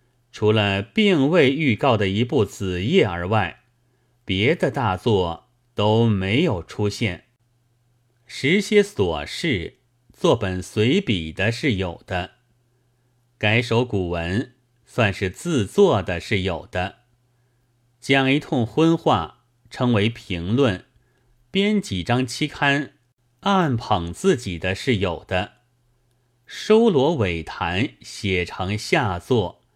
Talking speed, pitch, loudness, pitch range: 155 characters per minute, 120 Hz, -21 LUFS, 100-125 Hz